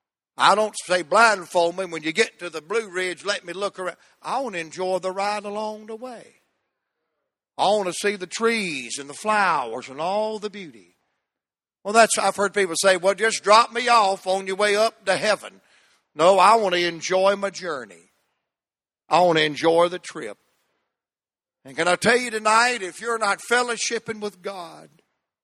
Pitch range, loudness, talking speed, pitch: 180-220 Hz, -21 LUFS, 190 wpm, 200 Hz